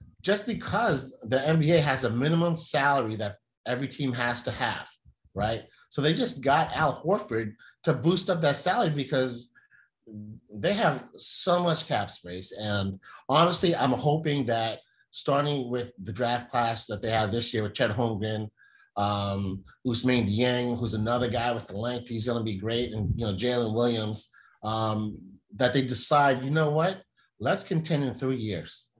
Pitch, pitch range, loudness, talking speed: 120 Hz, 110-140 Hz, -27 LUFS, 170 wpm